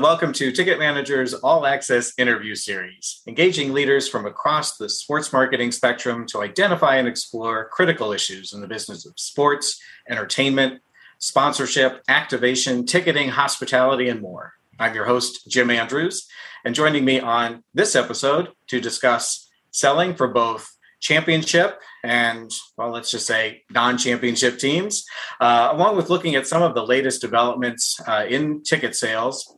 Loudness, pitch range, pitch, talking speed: -20 LUFS, 120-145 Hz, 130 Hz, 150 wpm